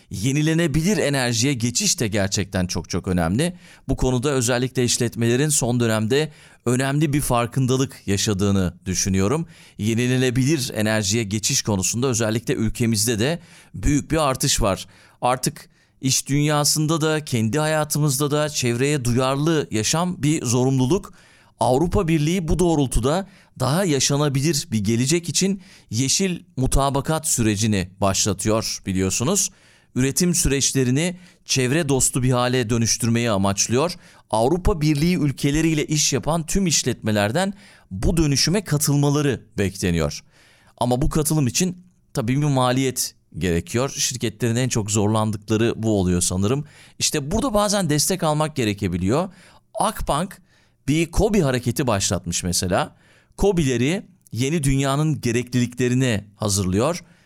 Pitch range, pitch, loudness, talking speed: 115-155 Hz, 130 Hz, -21 LUFS, 110 wpm